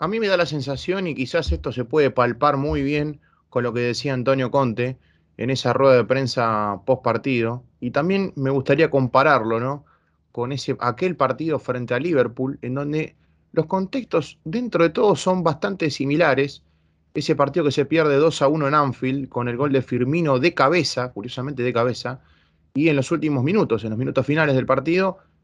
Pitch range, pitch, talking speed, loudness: 125-155 Hz, 135 Hz, 190 wpm, -21 LUFS